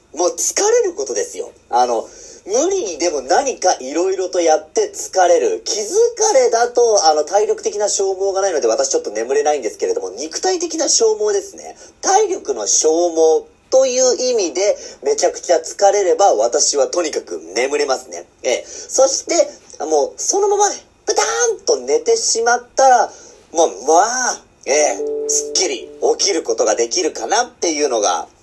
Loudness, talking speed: -16 LUFS, 330 characters per minute